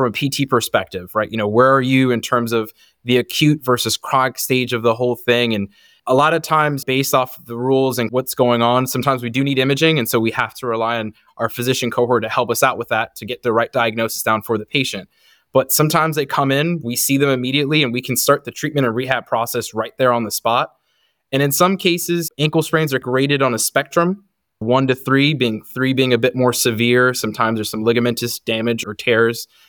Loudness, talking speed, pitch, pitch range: -17 LUFS, 235 wpm, 125 Hz, 115-135 Hz